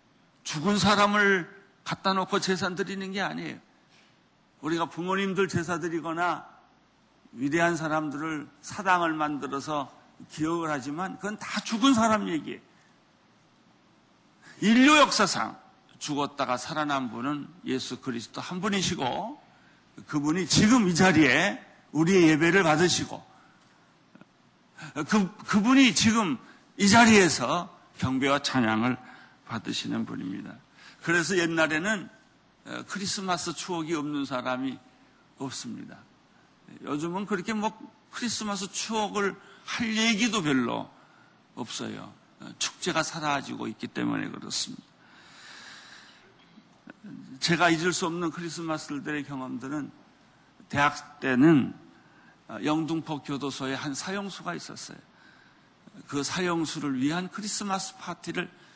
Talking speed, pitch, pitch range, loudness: 255 characters per minute, 175 Hz, 150-200 Hz, -26 LUFS